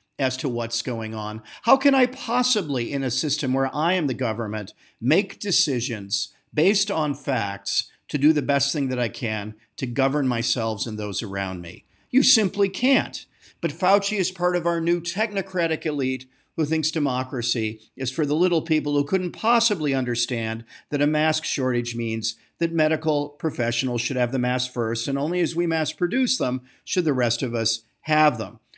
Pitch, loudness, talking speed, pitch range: 140 Hz, -23 LUFS, 185 wpm, 120-170 Hz